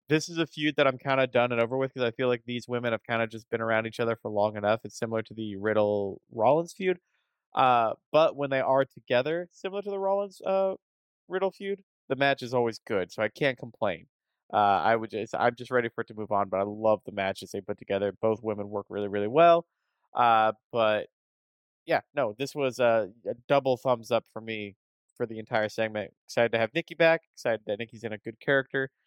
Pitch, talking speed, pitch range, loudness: 120 Hz, 235 wpm, 110-140 Hz, -28 LUFS